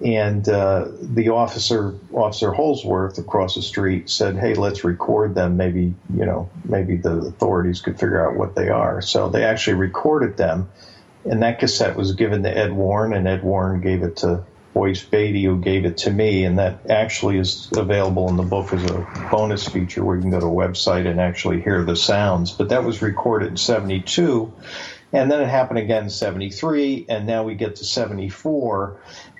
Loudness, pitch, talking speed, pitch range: -20 LUFS, 95 Hz, 195 wpm, 90-110 Hz